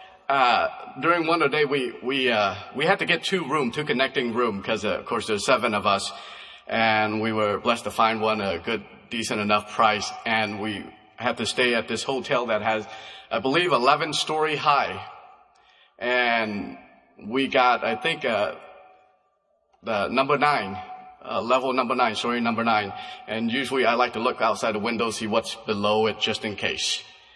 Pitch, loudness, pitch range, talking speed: 115 Hz, -24 LUFS, 110-145 Hz, 180 wpm